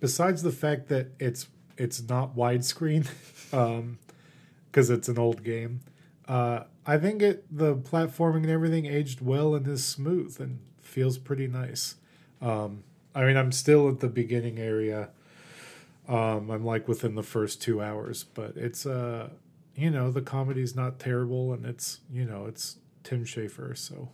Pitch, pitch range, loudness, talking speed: 130 Hz, 120-150 Hz, -29 LUFS, 160 wpm